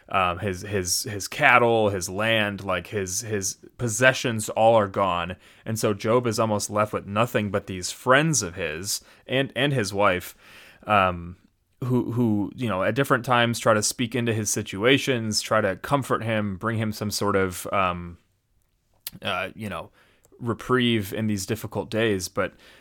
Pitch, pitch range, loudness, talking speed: 105 Hz, 100-120 Hz, -24 LUFS, 170 wpm